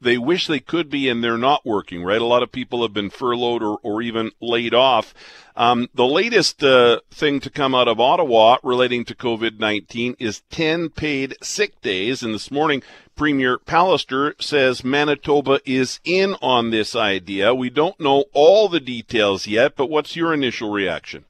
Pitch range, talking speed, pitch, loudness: 115-145 Hz, 180 wpm, 125 Hz, -19 LUFS